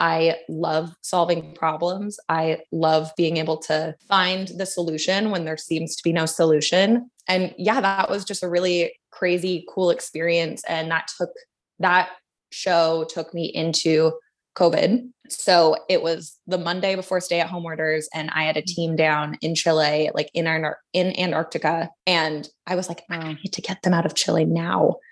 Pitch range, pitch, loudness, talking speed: 160-185 Hz, 165 Hz, -22 LUFS, 175 wpm